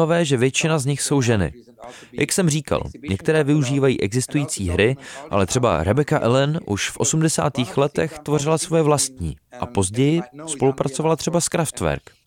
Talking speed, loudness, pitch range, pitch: 145 wpm, -20 LUFS, 115-155 Hz, 140 Hz